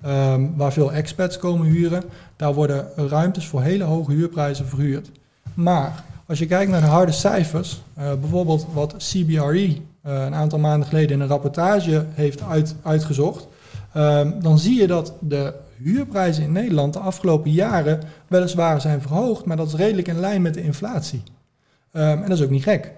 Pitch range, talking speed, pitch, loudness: 145-175 Hz, 180 wpm, 155 Hz, -20 LUFS